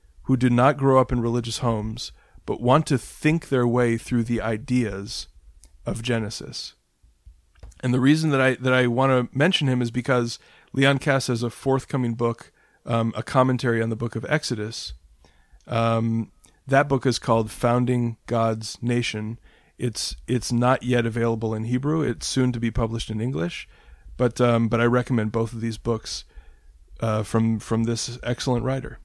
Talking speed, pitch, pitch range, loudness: 170 wpm, 120 Hz, 115-125 Hz, -23 LUFS